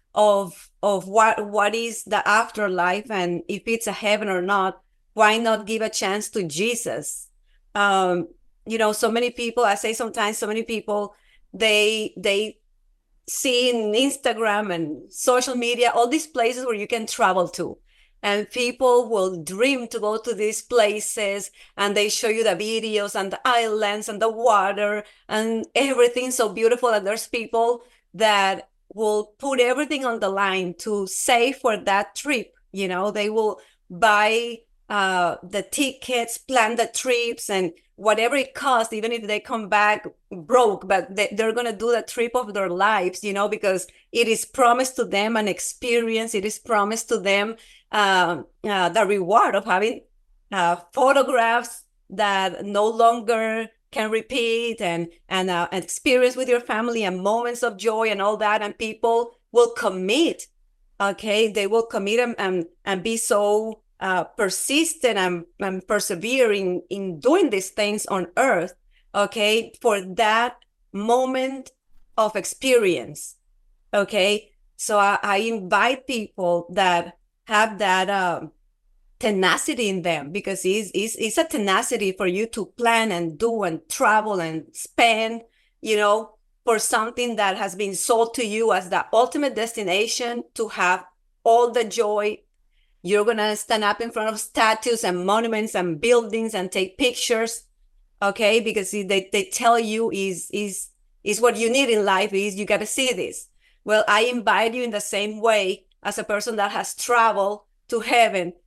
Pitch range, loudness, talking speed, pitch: 200-235 Hz, -22 LUFS, 160 wpm, 215 Hz